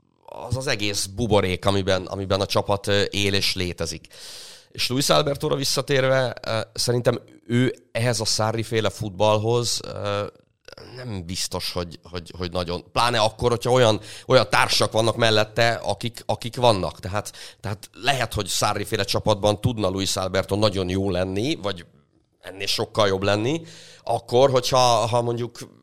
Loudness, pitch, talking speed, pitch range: -22 LUFS, 110 Hz, 135 wpm, 100-120 Hz